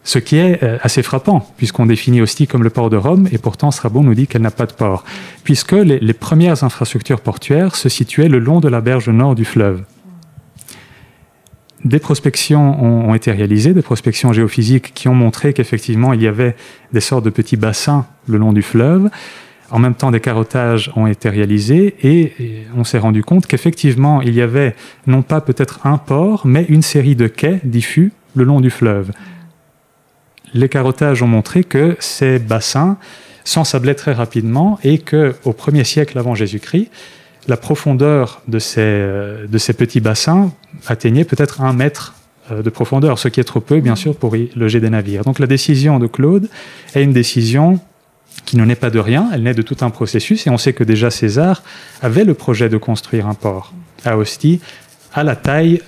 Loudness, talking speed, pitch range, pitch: -13 LUFS, 190 wpm, 115-150 Hz, 130 Hz